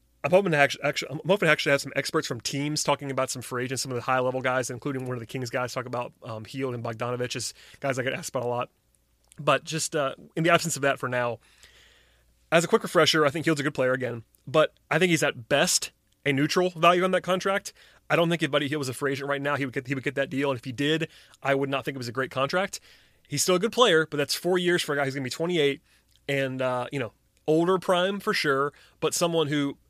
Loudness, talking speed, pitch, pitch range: -26 LUFS, 275 wpm, 140 Hz, 130-160 Hz